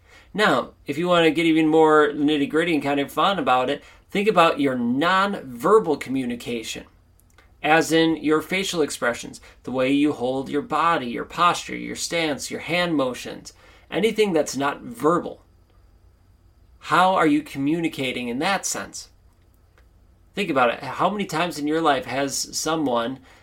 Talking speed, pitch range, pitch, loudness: 155 wpm, 115-165 Hz, 150 Hz, -22 LUFS